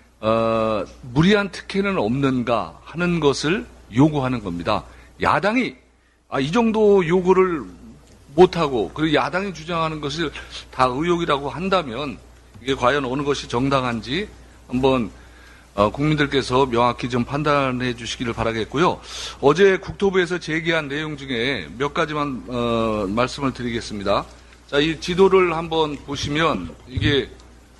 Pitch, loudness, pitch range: 140 Hz, -21 LUFS, 115-160 Hz